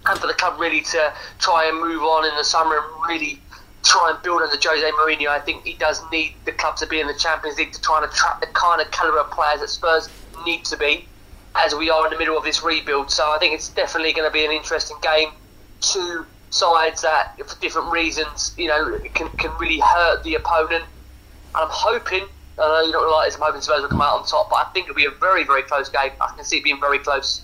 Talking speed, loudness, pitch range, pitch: 255 wpm, -19 LUFS, 150-160 Hz, 155 Hz